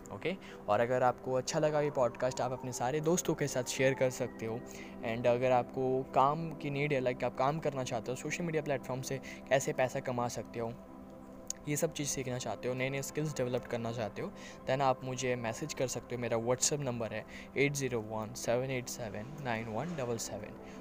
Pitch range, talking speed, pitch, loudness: 115-135 Hz, 190 wpm, 125 Hz, -34 LUFS